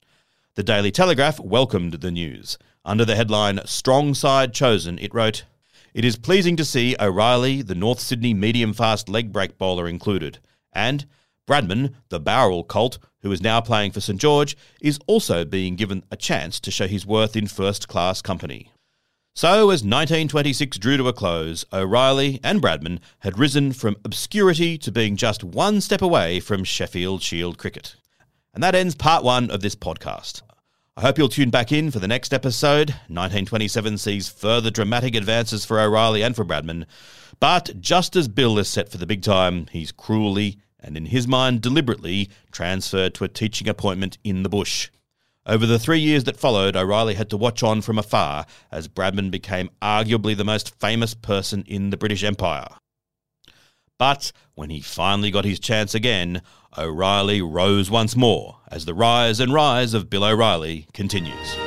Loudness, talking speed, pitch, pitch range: -21 LUFS, 175 wpm, 110 Hz, 95-125 Hz